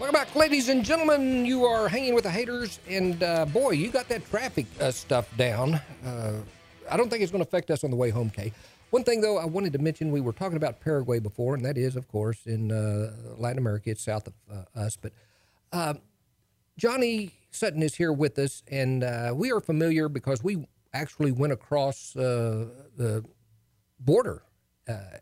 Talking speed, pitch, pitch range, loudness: 200 wpm, 140 Hz, 115-185 Hz, -27 LUFS